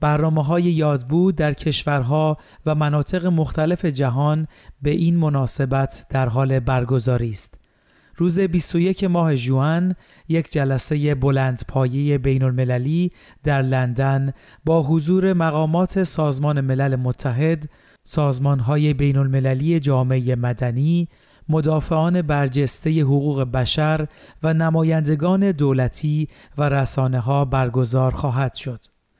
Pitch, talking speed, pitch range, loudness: 145 Hz, 110 wpm, 130-160 Hz, -20 LUFS